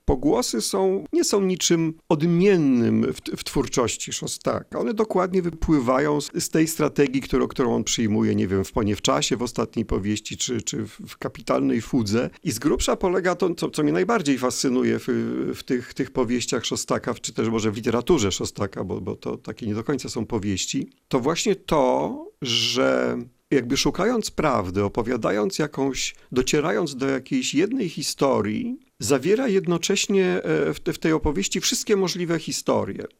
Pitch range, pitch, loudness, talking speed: 120-175 Hz, 140 Hz, -23 LUFS, 155 wpm